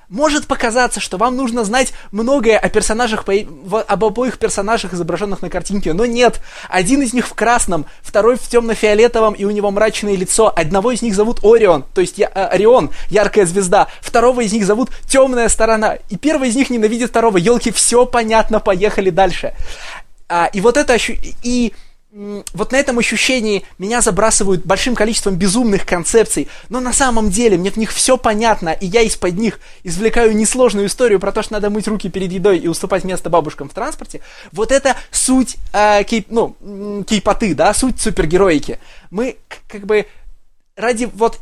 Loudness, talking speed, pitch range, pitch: -14 LUFS, 170 wpm, 200-240 Hz, 220 Hz